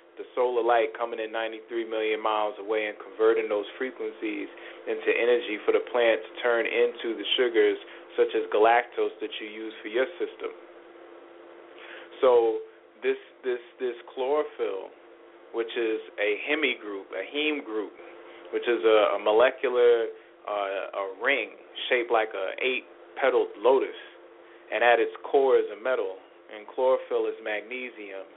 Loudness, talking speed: -27 LUFS, 150 wpm